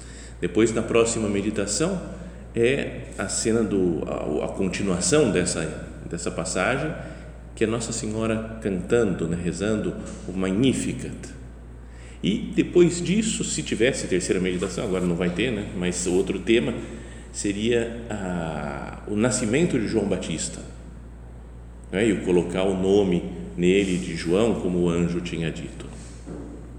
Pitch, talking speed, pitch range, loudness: 90 Hz, 130 wpm, 80-110 Hz, -24 LUFS